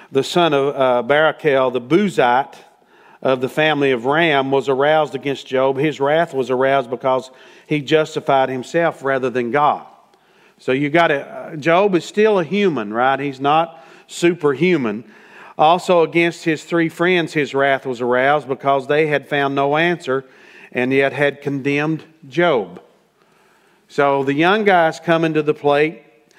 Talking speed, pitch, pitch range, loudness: 150 wpm, 145 Hz, 135-165 Hz, -17 LUFS